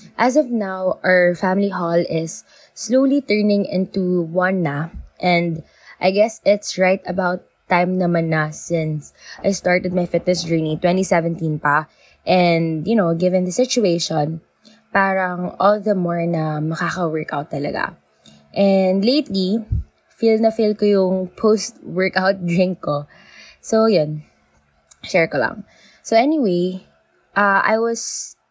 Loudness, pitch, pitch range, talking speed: -19 LUFS, 185 Hz, 165-200 Hz, 130 wpm